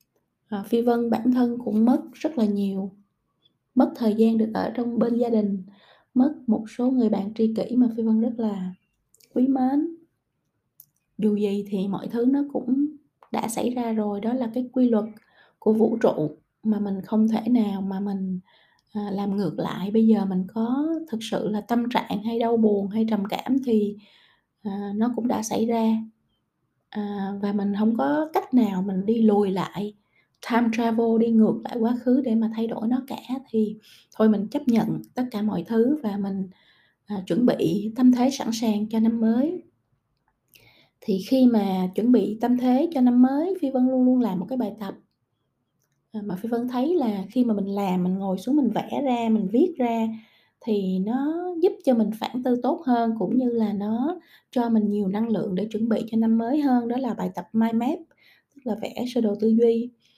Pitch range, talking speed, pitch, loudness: 205-250 Hz, 200 wpm, 225 Hz, -24 LUFS